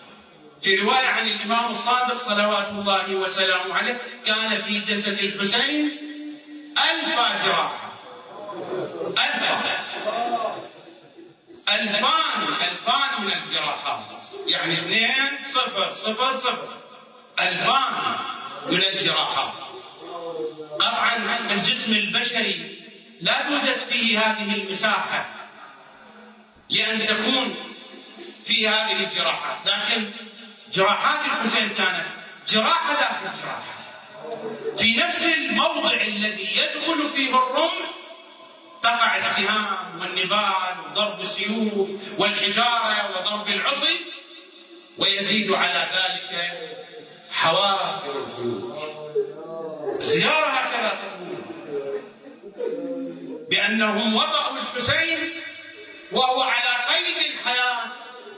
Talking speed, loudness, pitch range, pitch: 80 wpm, -21 LUFS, 205-275 Hz, 230 Hz